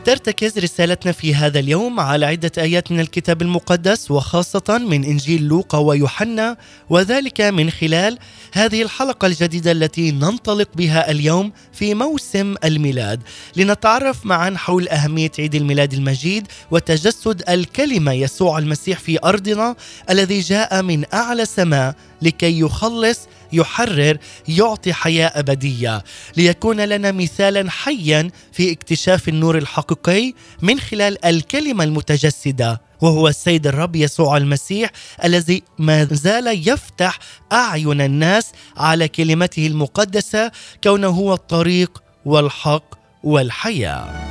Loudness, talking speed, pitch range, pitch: -17 LUFS, 115 wpm, 150-200 Hz, 170 Hz